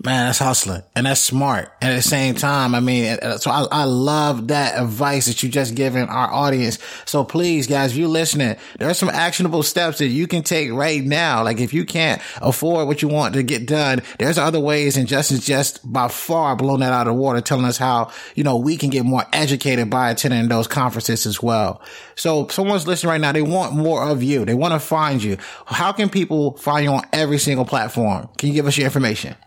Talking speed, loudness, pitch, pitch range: 230 wpm, -18 LUFS, 140 Hz, 125-150 Hz